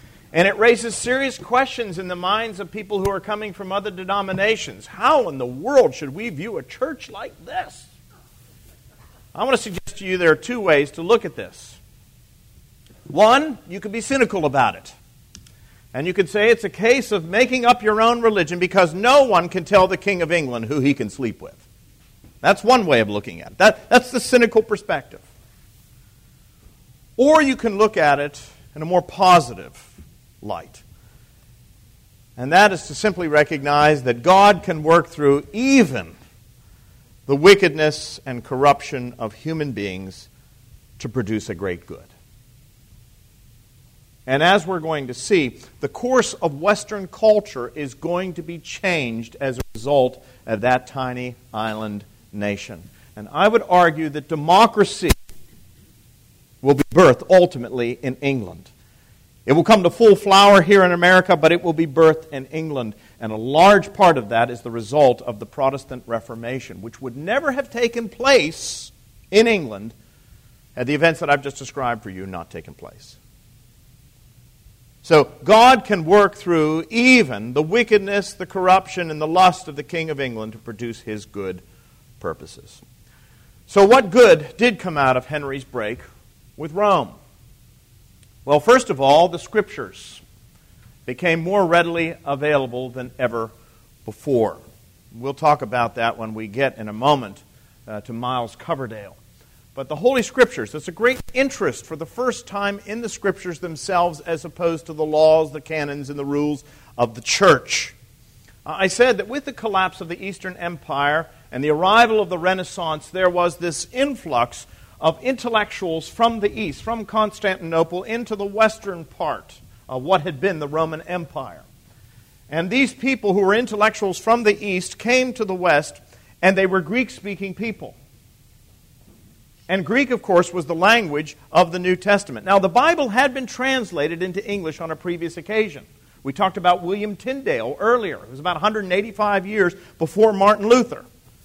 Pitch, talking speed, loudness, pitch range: 160 Hz, 165 wpm, -18 LUFS, 125-200 Hz